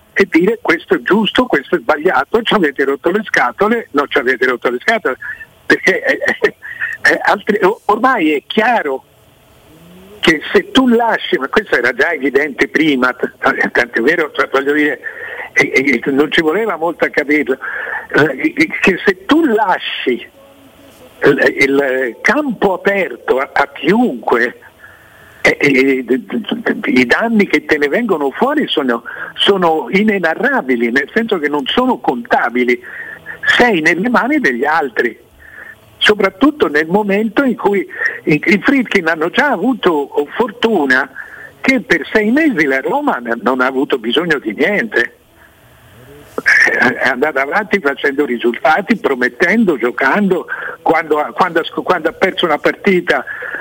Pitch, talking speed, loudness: 215 Hz, 130 wpm, -13 LUFS